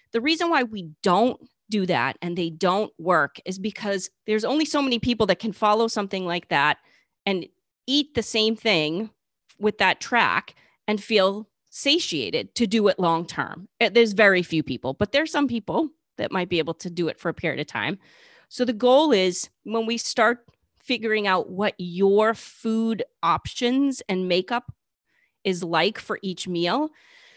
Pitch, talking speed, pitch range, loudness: 210 Hz, 180 wpm, 180-240 Hz, -23 LUFS